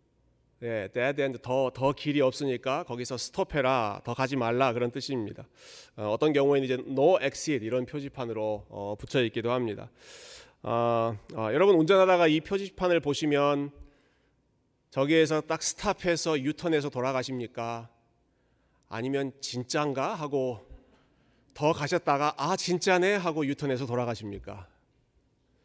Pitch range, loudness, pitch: 120-155 Hz, -28 LUFS, 135 Hz